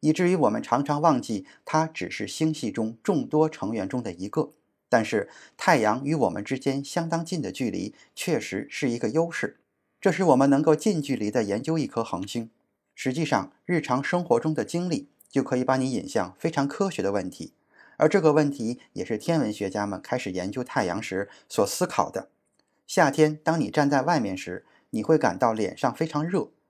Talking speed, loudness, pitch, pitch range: 285 characters per minute, -26 LUFS, 140 Hz, 115-160 Hz